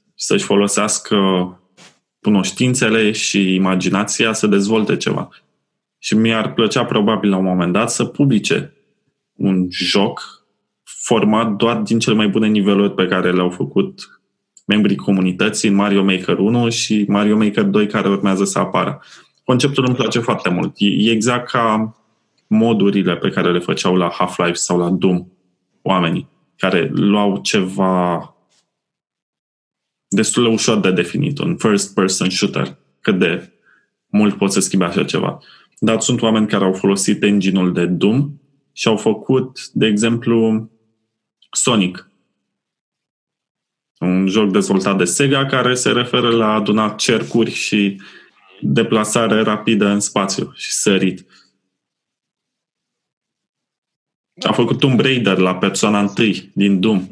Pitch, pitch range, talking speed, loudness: 105 Hz, 95-110 Hz, 130 wpm, -16 LUFS